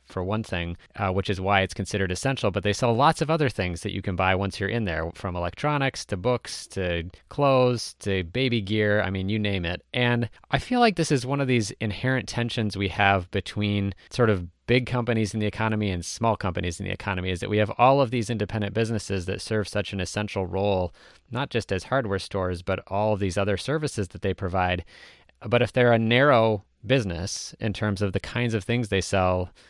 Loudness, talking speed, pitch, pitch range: -25 LUFS, 220 wpm, 105 Hz, 95-120 Hz